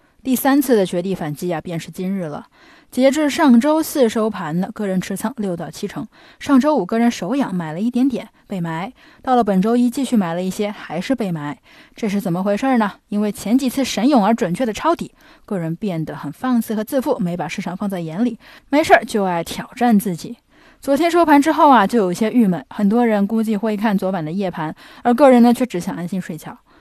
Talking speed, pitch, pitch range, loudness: 320 characters per minute, 220 Hz, 185-265 Hz, -18 LUFS